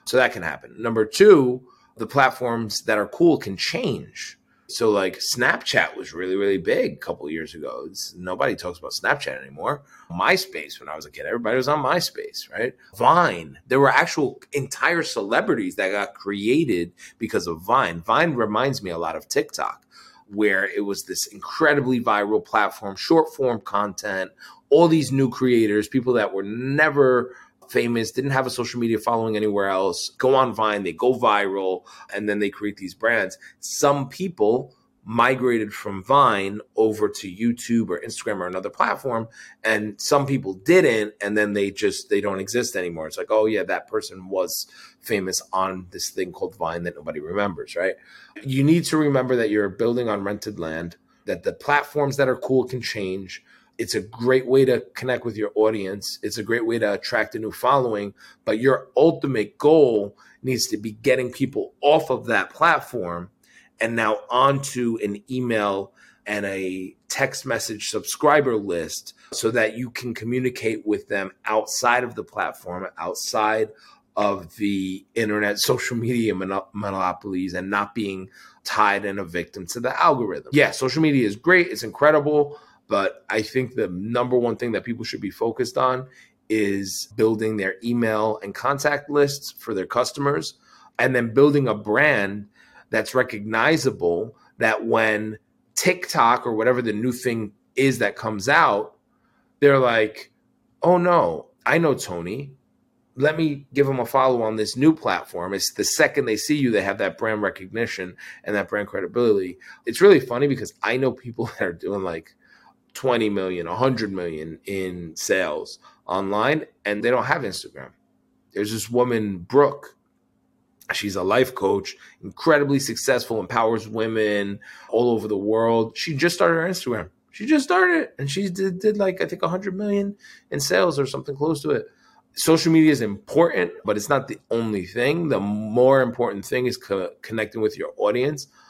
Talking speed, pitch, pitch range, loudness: 170 wpm, 115 Hz, 105-140 Hz, -22 LUFS